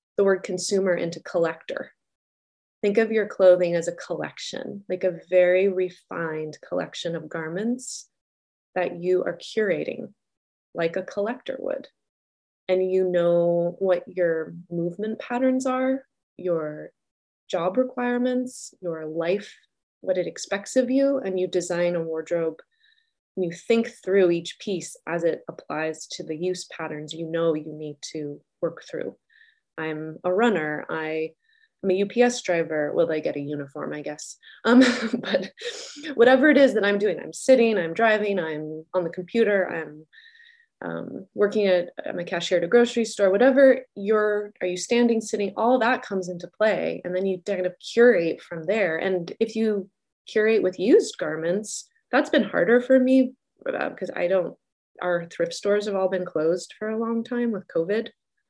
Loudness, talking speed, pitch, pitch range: -24 LUFS, 160 wpm, 190 Hz, 170-240 Hz